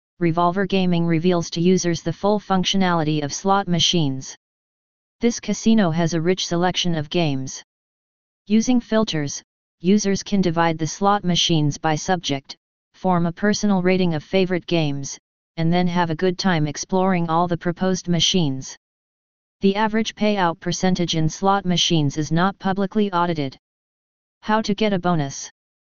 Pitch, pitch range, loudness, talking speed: 175 Hz, 165-195 Hz, -20 LUFS, 145 wpm